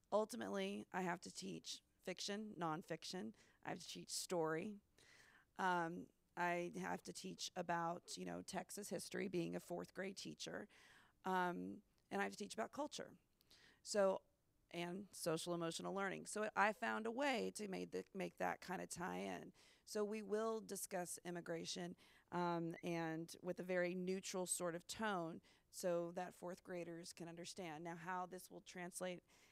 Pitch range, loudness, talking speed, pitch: 170-195 Hz, -46 LUFS, 160 wpm, 180 Hz